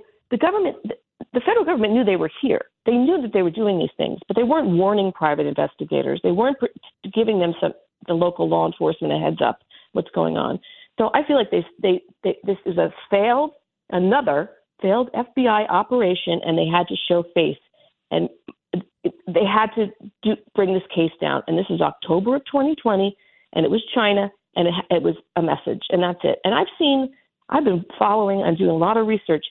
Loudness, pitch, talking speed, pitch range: -21 LUFS, 205 Hz, 200 wpm, 175-250 Hz